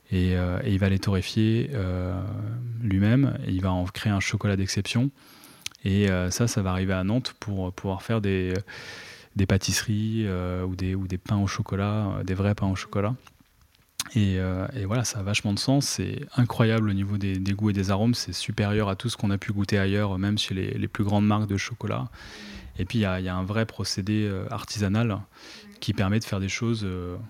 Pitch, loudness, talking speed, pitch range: 100 Hz, -26 LUFS, 220 wpm, 95-110 Hz